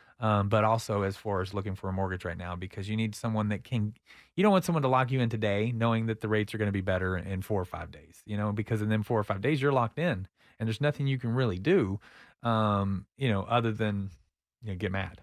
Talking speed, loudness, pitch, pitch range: 270 wpm, -30 LUFS, 105 Hz, 95-115 Hz